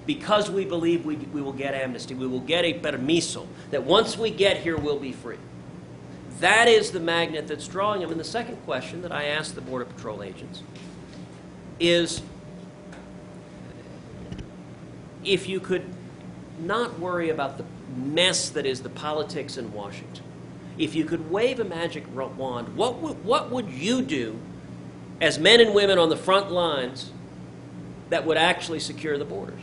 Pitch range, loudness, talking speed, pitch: 125-175 Hz, -24 LUFS, 165 wpm, 155 Hz